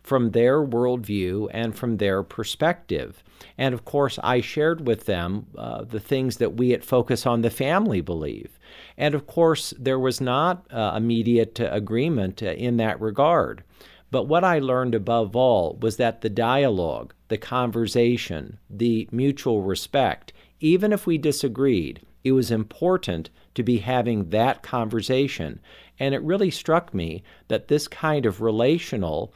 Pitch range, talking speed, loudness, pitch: 110-140 Hz, 155 wpm, -23 LUFS, 120 Hz